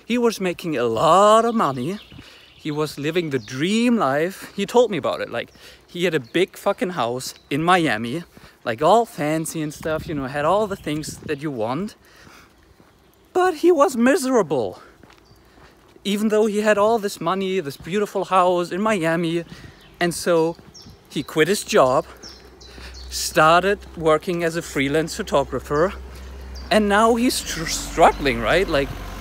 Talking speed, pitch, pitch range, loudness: 155 wpm, 170 Hz, 145-210 Hz, -20 LUFS